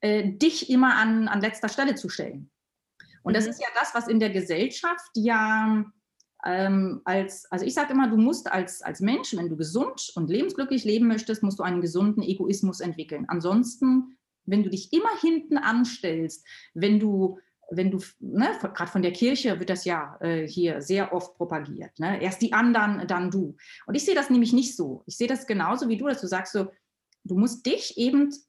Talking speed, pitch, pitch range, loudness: 200 wpm, 210 Hz, 185-245 Hz, -25 LUFS